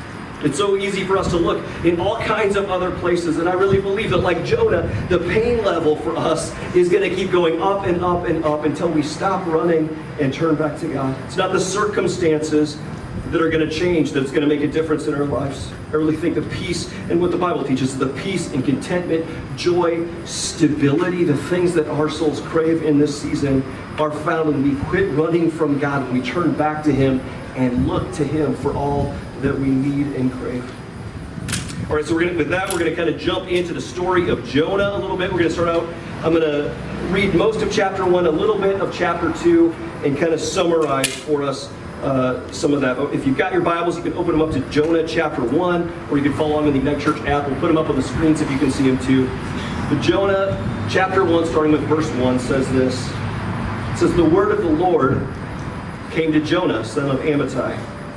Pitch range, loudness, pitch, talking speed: 140-175 Hz, -19 LUFS, 155 Hz, 225 wpm